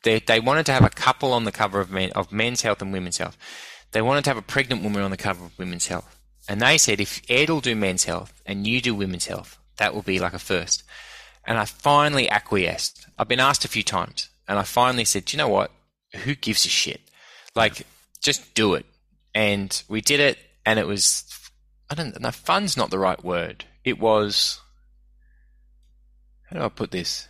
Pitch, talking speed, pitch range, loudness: 105 Hz, 215 wpm, 95-120 Hz, -22 LUFS